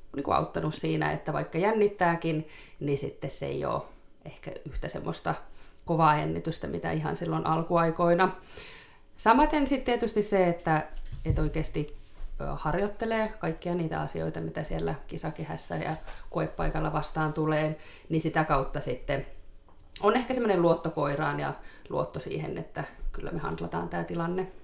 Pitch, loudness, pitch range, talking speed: 155 Hz, -29 LUFS, 120-185 Hz, 130 wpm